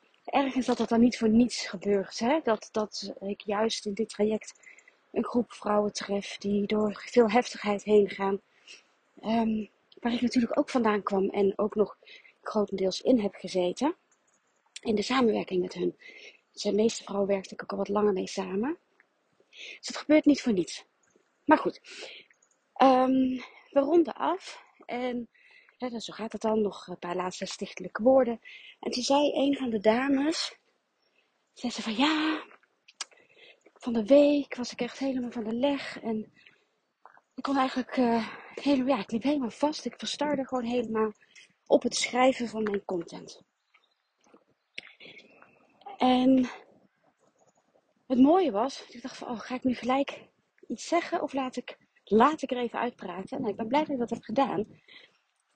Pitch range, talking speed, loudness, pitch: 215-280 Hz, 170 wpm, -28 LUFS, 245 Hz